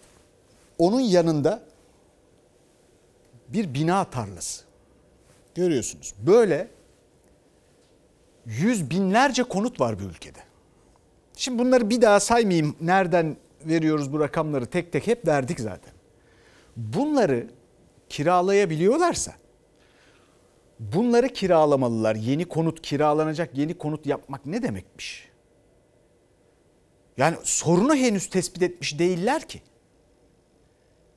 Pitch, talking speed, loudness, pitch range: 165 Hz, 90 wpm, -23 LUFS, 145-200 Hz